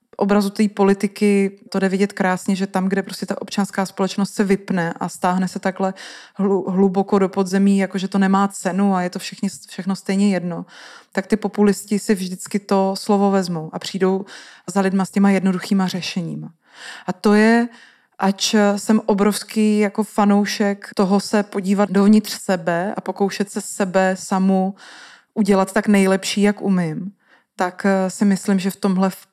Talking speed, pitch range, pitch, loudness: 160 wpm, 190-205 Hz, 195 Hz, -19 LUFS